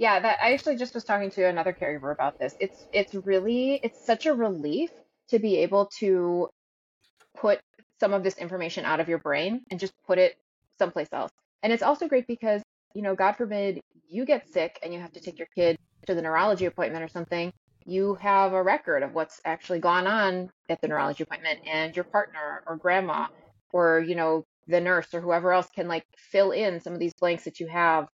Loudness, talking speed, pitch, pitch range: -27 LUFS, 215 wpm, 180 Hz, 165-205 Hz